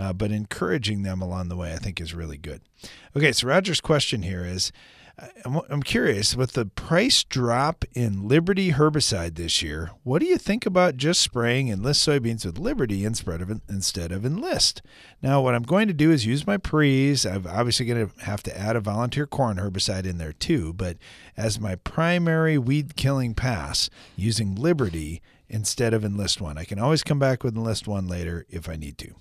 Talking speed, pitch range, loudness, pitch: 195 wpm, 95-140 Hz, -24 LUFS, 115 Hz